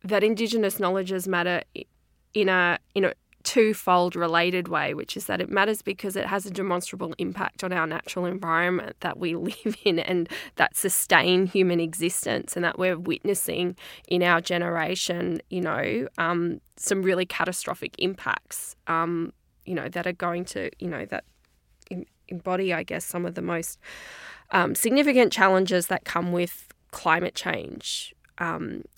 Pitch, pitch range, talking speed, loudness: 180 Hz, 170-195 Hz, 155 wpm, -25 LUFS